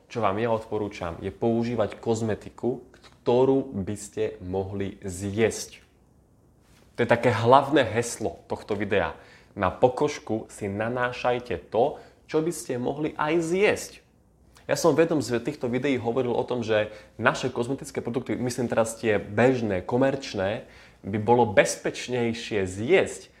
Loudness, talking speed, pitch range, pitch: -26 LUFS, 135 wpm, 105-130 Hz, 120 Hz